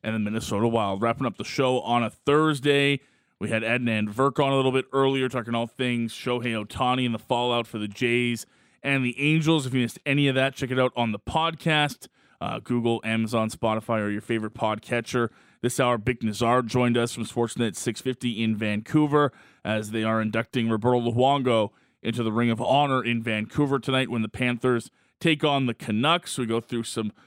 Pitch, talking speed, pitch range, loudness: 120 Hz, 200 wpm, 115-130 Hz, -25 LUFS